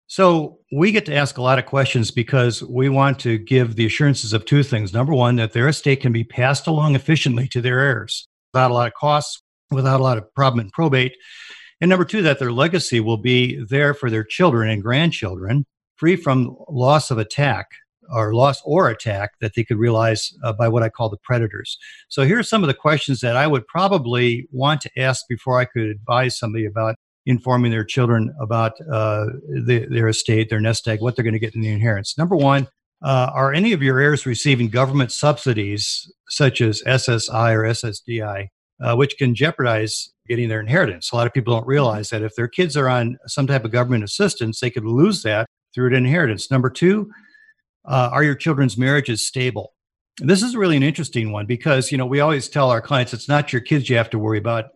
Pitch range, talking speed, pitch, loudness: 115-145 Hz, 215 wpm, 125 Hz, -19 LUFS